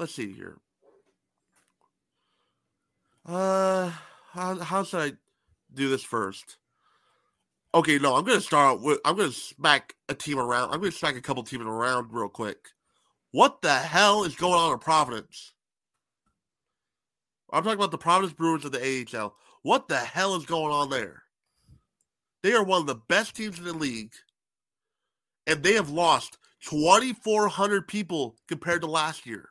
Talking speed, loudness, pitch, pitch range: 155 wpm, -25 LUFS, 165 Hz, 135-190 Hz